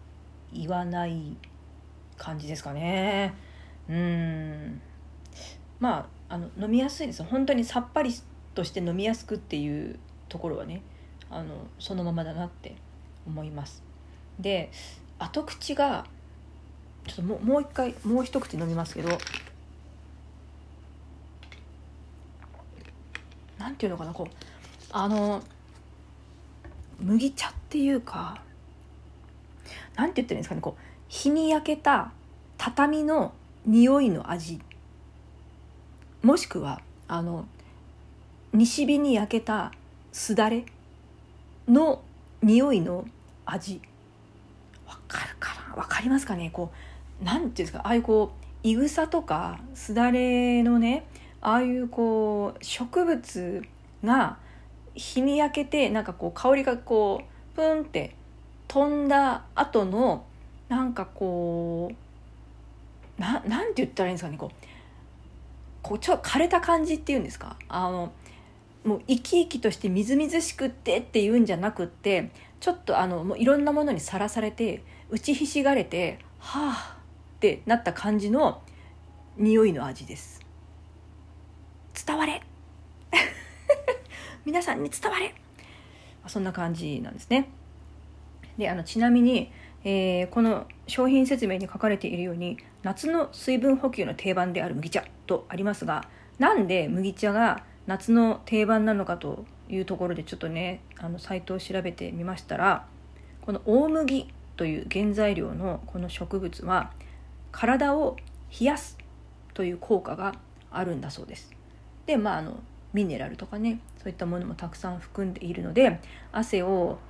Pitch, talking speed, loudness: 185 Hz, 255 characters per minute, -27 LUFS